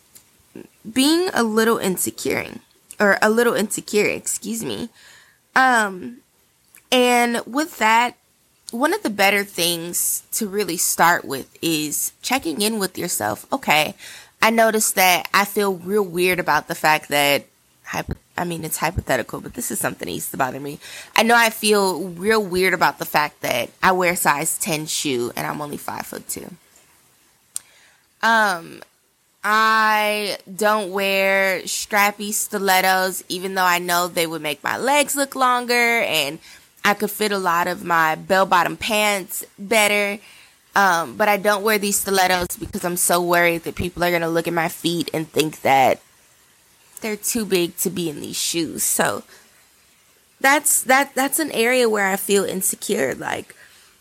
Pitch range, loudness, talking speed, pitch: 175-220 Hz, -19 LUFS, 160 wpm, 200 Hz